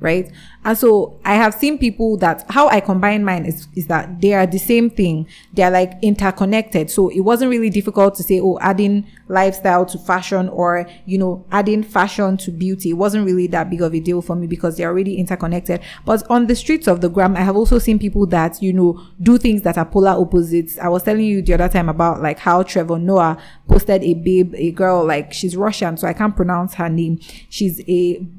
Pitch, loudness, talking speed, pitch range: 185 Hz, -16 LUFS, 225 wpm, 175-205 Hz